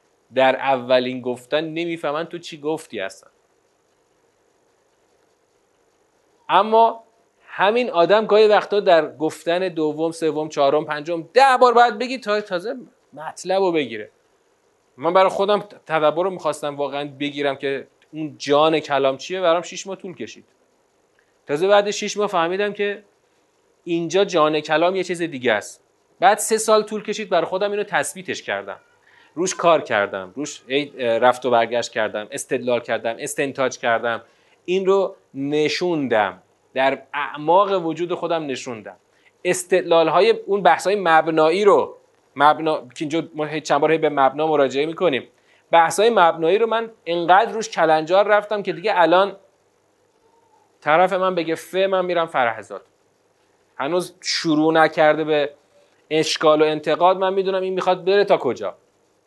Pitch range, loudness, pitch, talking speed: 150-210 Hz, -19 LUFS, 170 Hz, 140 wpm